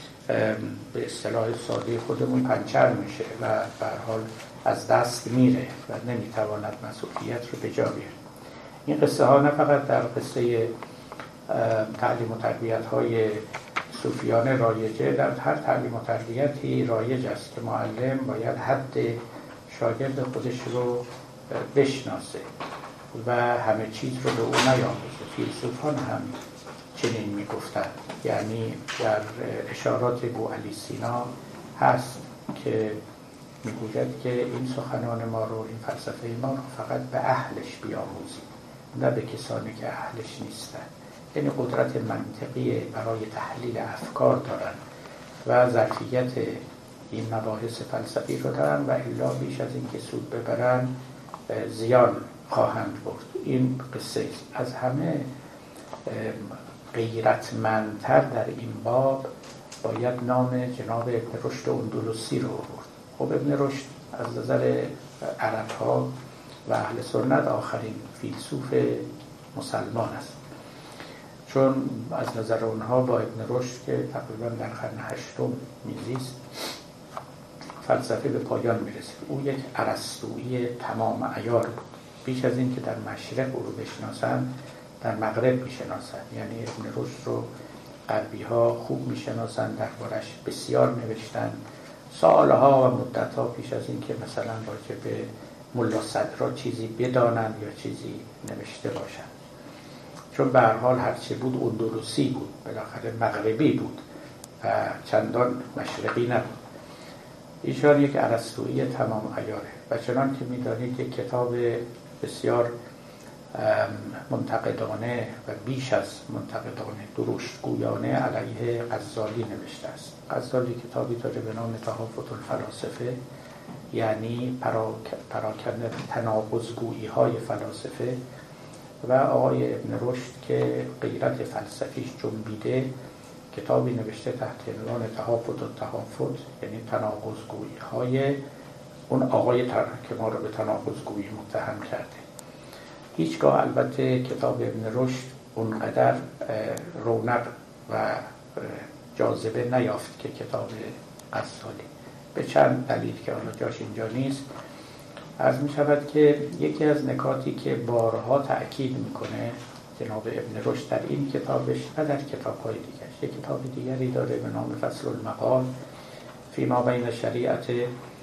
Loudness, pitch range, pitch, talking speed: -27 LUFS, 110-130 Hz, 120 Hz, 120 wpm